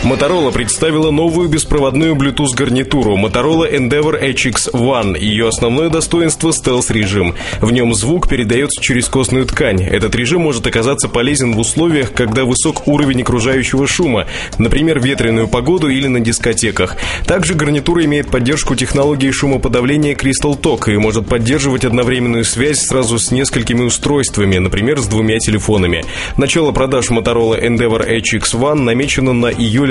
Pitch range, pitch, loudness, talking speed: 115-145 Hz, 130 Hz, -13 LUFS, 140 wpm